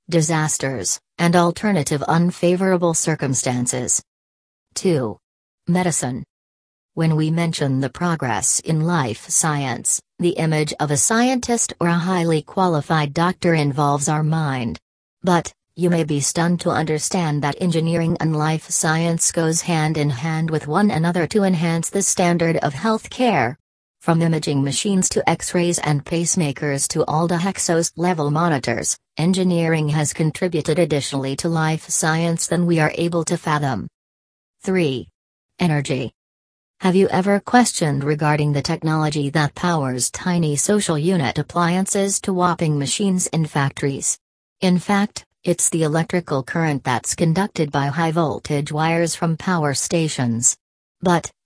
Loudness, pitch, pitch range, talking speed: -19 LUFS, 160 Hz, 145-175 Hz, 135 wpm